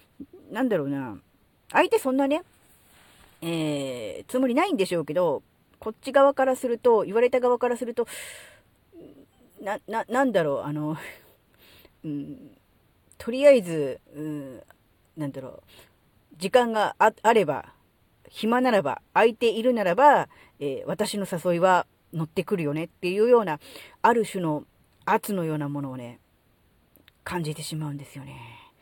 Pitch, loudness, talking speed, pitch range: 195 Hz, -25 LUFS, 275 characters per minute, 150-245 Hz